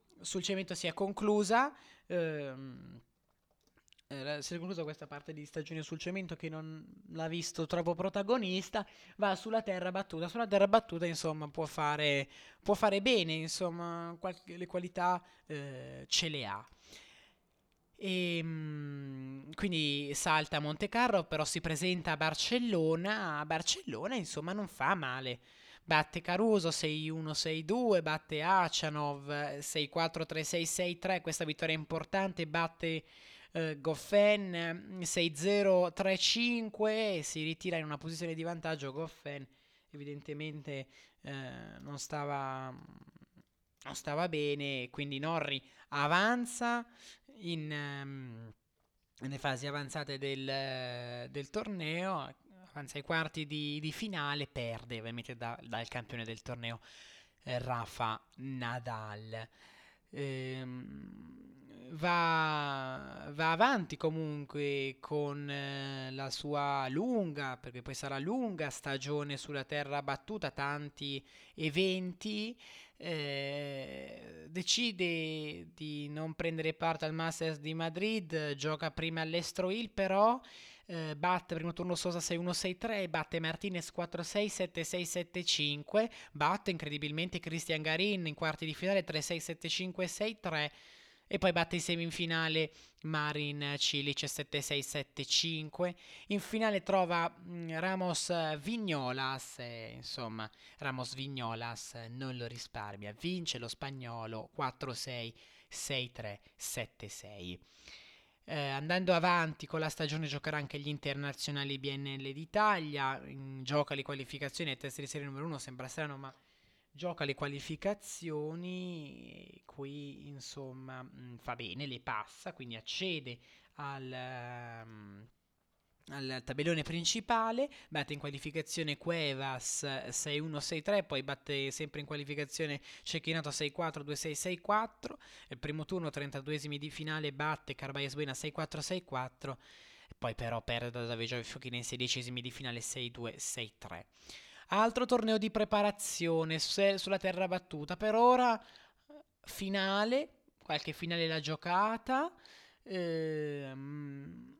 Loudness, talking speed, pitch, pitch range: -36 LUFS, 110 wpm, 155 Hz, 140-175 Hz